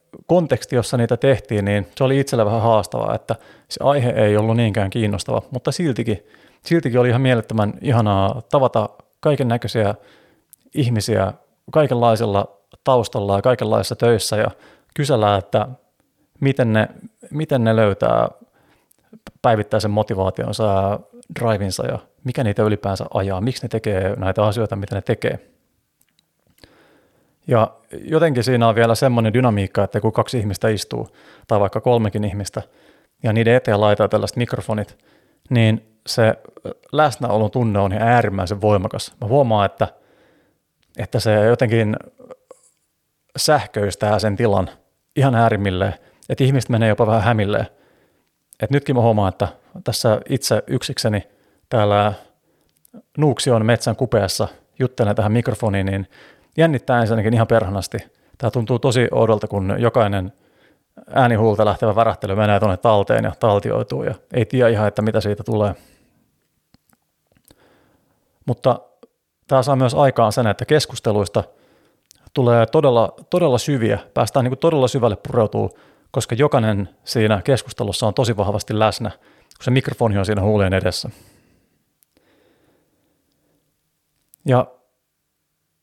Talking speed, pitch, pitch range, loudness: 125 wpm, 115 Hz, 105-125 Hz, -19 LUFS